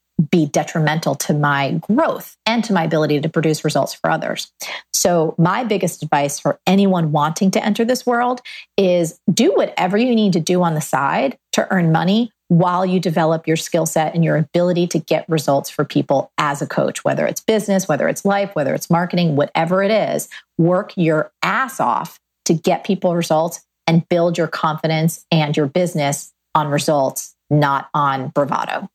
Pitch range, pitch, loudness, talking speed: 155-190 Hz, 165 Hz, -18 LUFS, 180 wpm